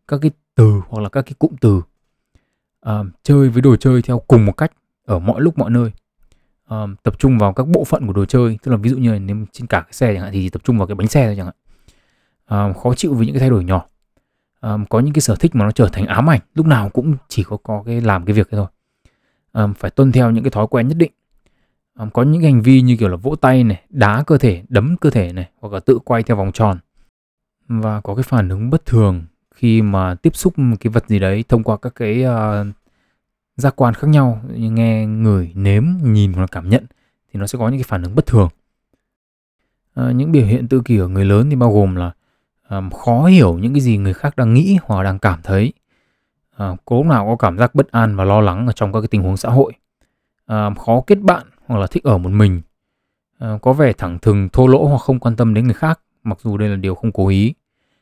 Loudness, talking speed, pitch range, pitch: -15 LUFS, 250 wpm, 100-130 Hz, 115 Hz